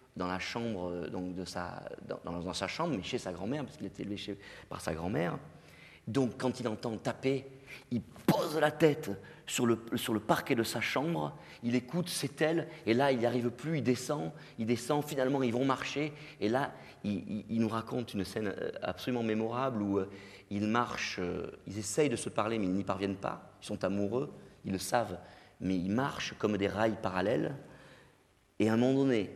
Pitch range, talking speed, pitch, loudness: 100-130 Hz, 205 wpm, 115 Hz, -34 LUFS